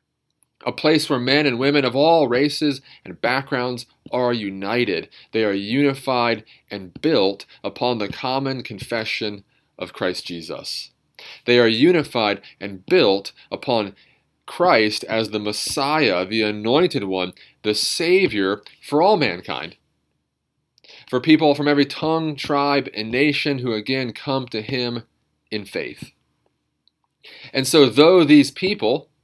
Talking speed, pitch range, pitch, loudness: 130 wpm, 110-145 Hz, 125 Hz, -20 LUFS